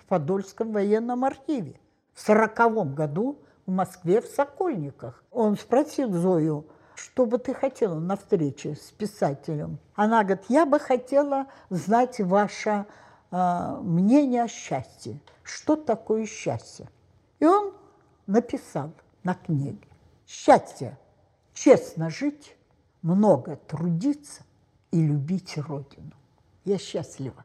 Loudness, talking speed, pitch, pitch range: -25 LUFS, 110 wpm, 200 Hz, 155-245 Hz